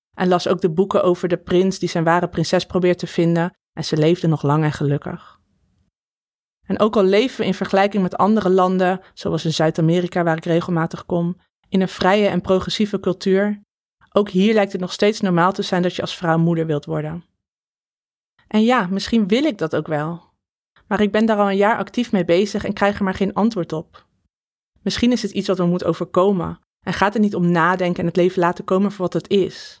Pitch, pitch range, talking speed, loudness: 185 Hz, 170-200 Hz, 220 wpm, -19 LUFS